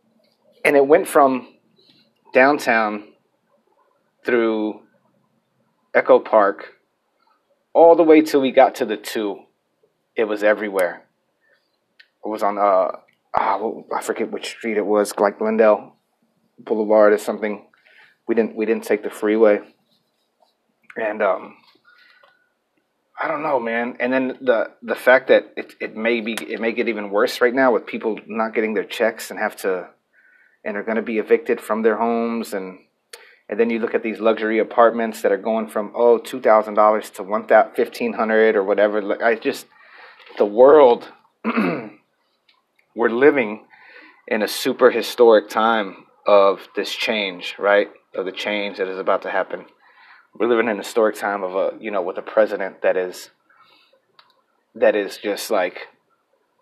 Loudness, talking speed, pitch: -19 LUFS, 155 wpm, 115 Hz